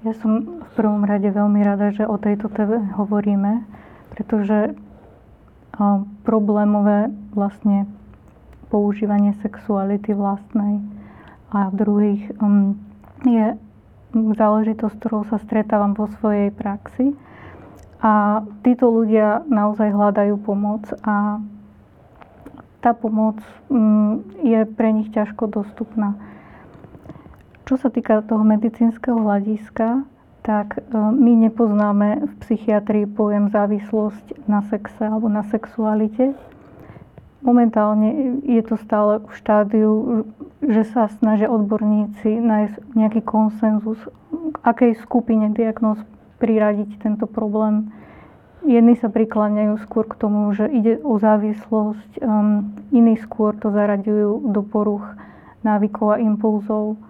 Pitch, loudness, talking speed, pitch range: 215 Hz, -19 LUFS, 105 wpm, 210-225 Hz